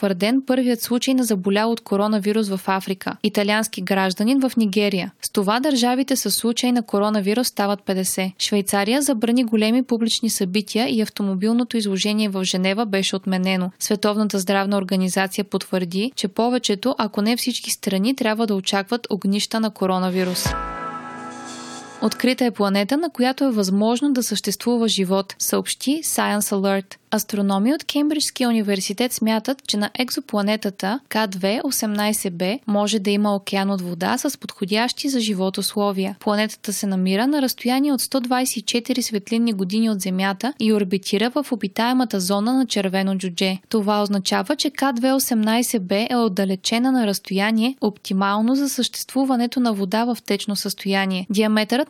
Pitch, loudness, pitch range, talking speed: 215 Hz, -21 LUFS, 200-240 Hz, 135 wpm